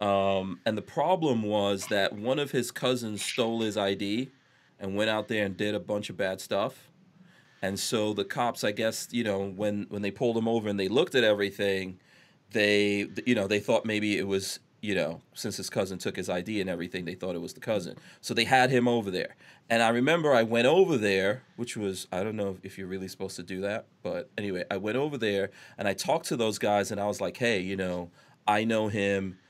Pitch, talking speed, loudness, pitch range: 105 Hz, 230 wpm, -29 LUFS, 95-115 Hz